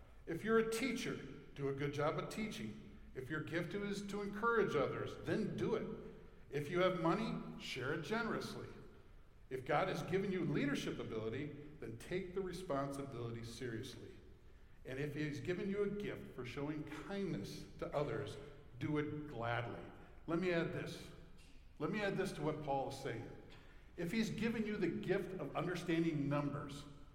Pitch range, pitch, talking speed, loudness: 140-185 Hz, 150 Hz, 170 wpm, -41 LUFS